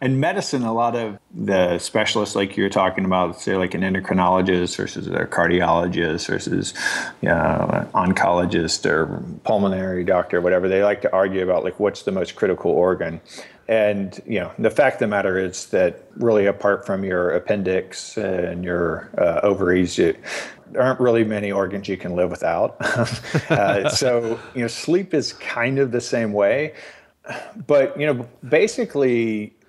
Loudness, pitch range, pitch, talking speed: -21 LUFS, 95-120 Hz, 100 Hz, 170 wpm